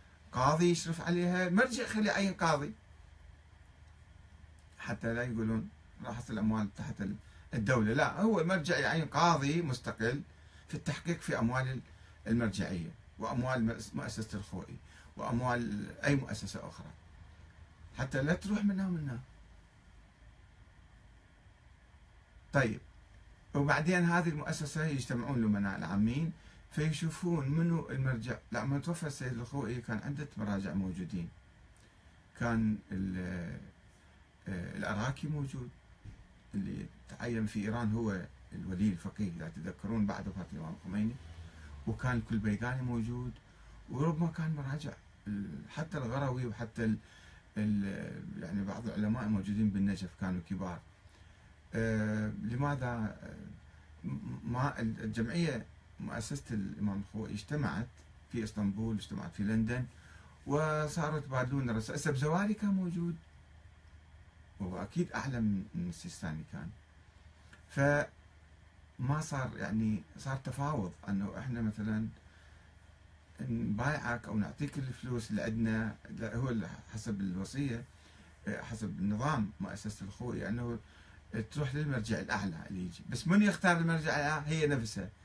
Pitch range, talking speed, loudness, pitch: 95-140 Hz, 105 wpm, -36 LUFS, 110 Hz